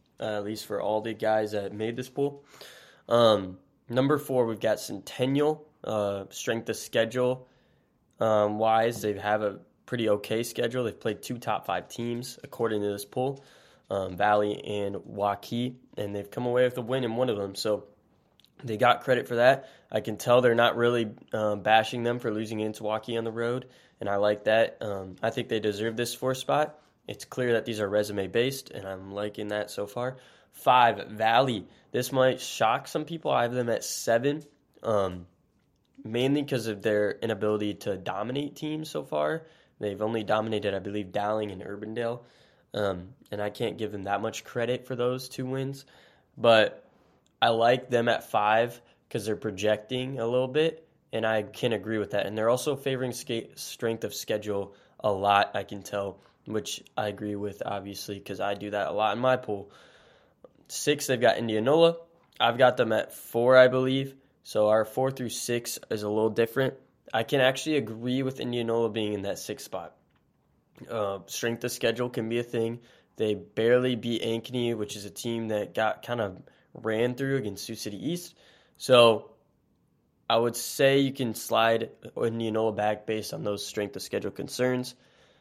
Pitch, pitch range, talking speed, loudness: 115 Hz, 105-125 Hz, 185 wpm, -28 LUFS